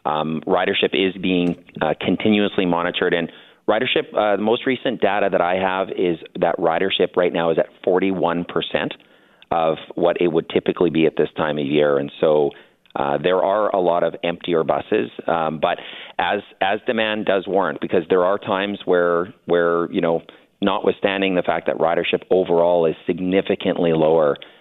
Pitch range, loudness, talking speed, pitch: 85-95 Hz, -20 LUFS, 165 wpm, 90 Hz